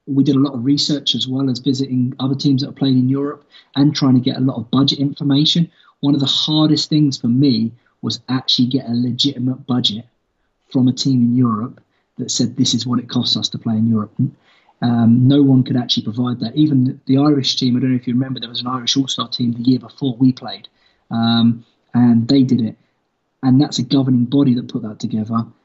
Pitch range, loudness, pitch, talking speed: 120-140 Hz, -17 LUFS, 130 Hz, 230 wpm